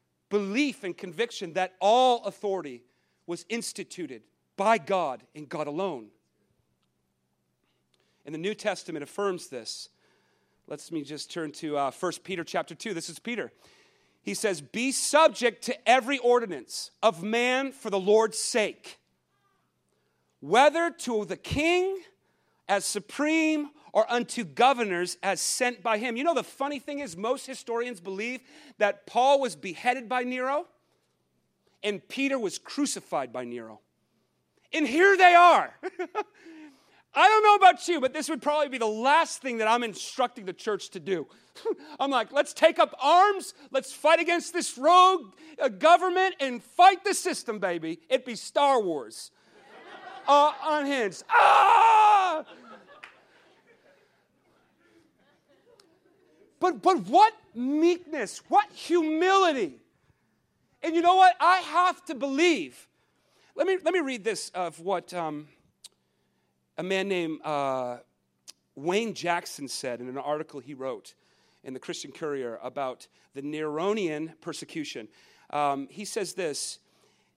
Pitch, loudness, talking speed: 245 Hz, -25 LUFS, 135 wpm